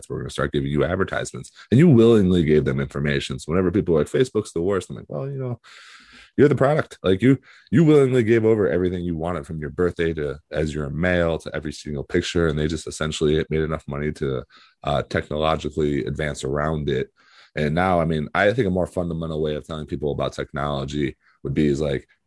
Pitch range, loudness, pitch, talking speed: 75-90 Hz, -22 LUFS, 80 Hz, 215 wpm